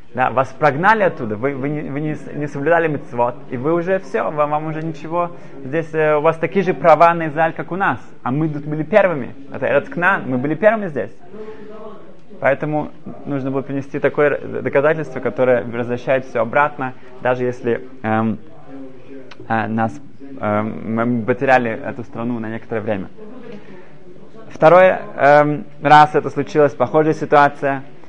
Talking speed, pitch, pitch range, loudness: 155 wpm, 145 Hz, 130-160 Hz, -17 LUFS